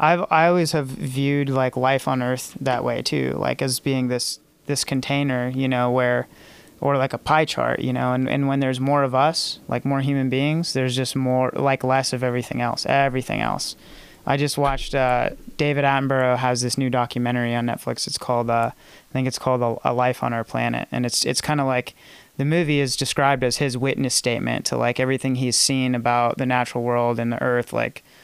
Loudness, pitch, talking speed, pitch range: -22 LUFS, 130 Hz, 215 wpm, 125-140 Hz